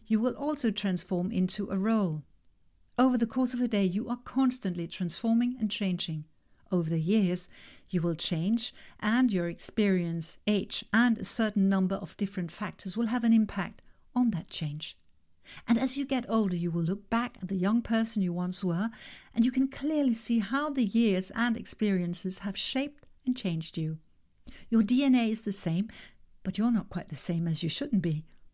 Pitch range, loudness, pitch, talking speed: 175-230 Hz, -30 LUFS, 200 Hz, 185 wpm